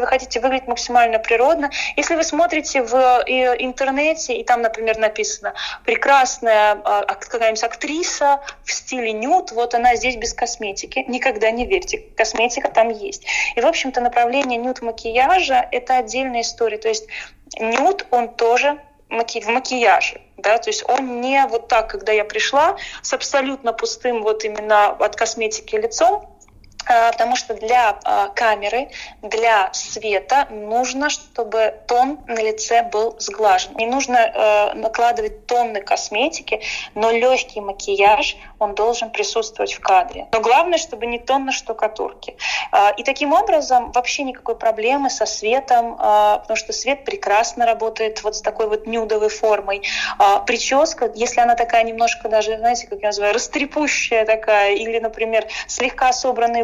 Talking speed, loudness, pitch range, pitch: 145 wpm, -18 LUFS, 220-275 Hz, 240 Hz